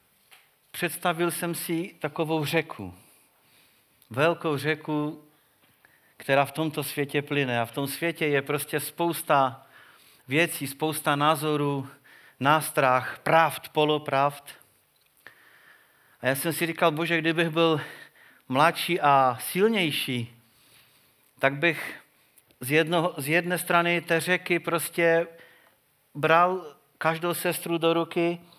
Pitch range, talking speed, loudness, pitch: 140-170 Hz, 105 wpm, -25 LUFS, 155 Hz